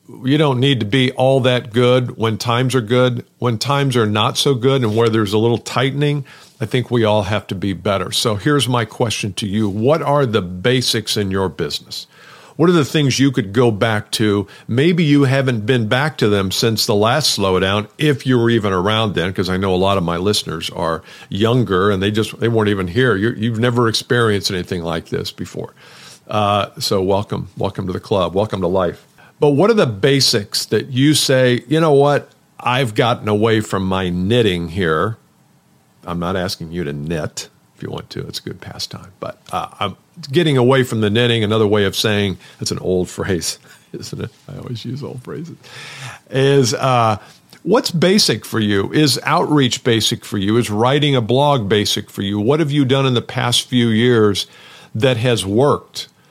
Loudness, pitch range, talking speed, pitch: -16 LUFS, 105-135 Hz, 205 wpm, 115 Hz